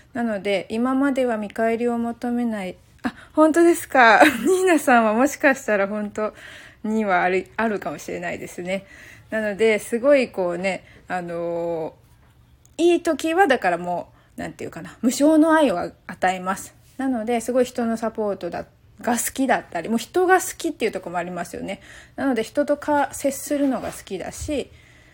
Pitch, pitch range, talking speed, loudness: 230 Hz, 195-275 Hz, 340 characters per minute, -21 LUFS